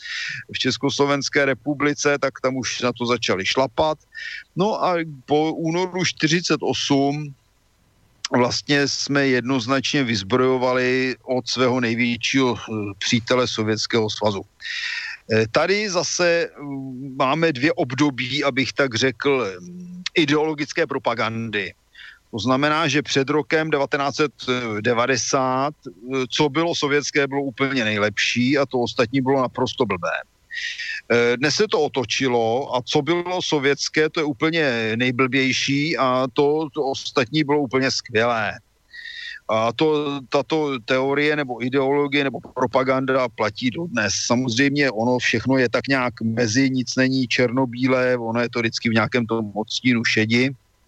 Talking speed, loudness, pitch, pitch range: 120 wpm, -21 LUFS, 135 Hz, 120-150 Hz